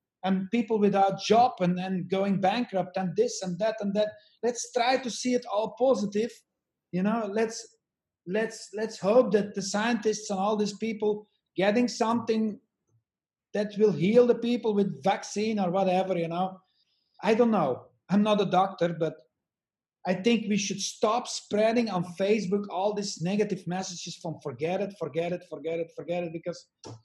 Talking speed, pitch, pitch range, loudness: 170 wpm, 205 Hz, 185-220 Hz, -28 LUFS